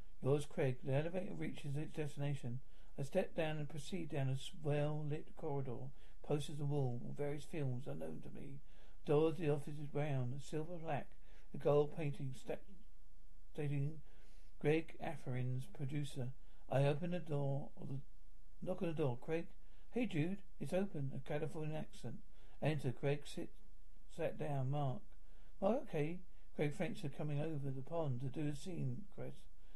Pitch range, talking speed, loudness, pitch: 135-160 Hz, 165 wpm, -42 LUFS, 145 Hz